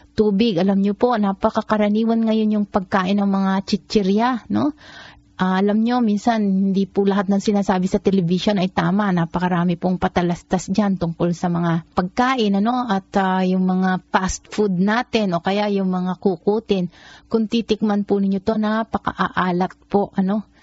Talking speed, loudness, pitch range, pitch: 155 wpm, -20 LUFS, 185-215 Hz, 200 Hz